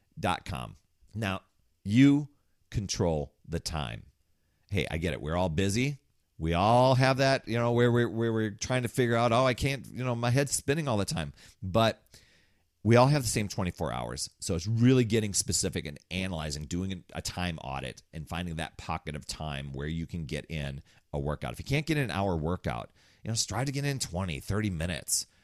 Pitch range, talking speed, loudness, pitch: 80-120 Hz, 205 wpm, -29 LUFS, 95 Hz